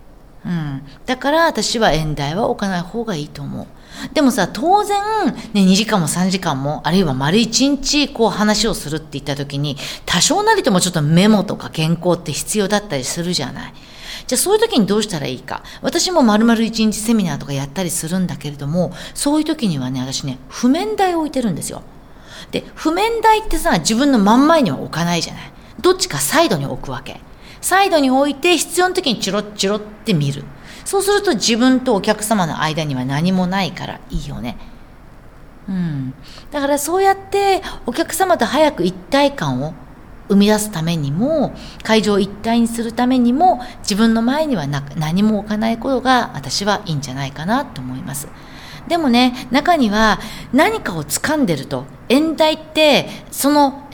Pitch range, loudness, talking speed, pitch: 170-280 Hz, -17 LUFS, 350 characters per minute, 220 Hz